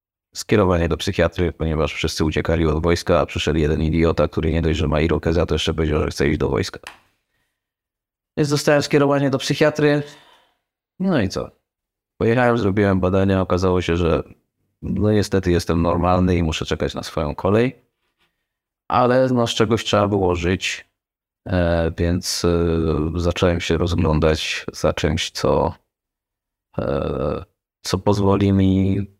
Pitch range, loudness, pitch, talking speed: 80-105 Hz, -19 LUFS, 90 Hz, 140 wpm